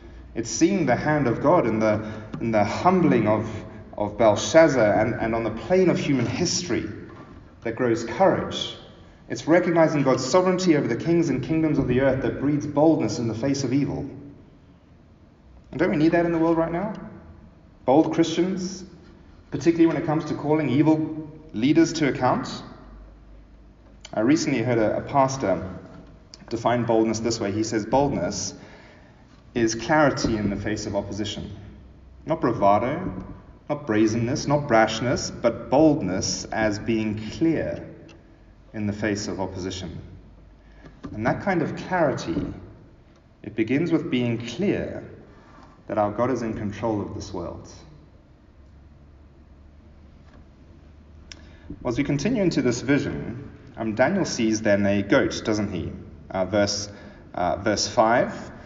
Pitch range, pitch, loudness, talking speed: 95-145 Hz, 110 Hz, -23 LUFS, 145 wpm